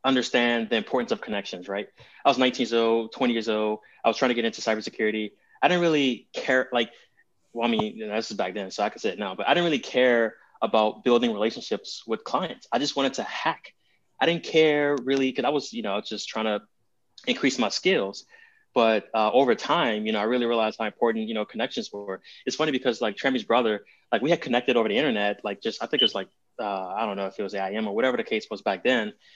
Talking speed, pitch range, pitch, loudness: 245 wpm, 110-135 Hz, 115 Hz, -25 LUFS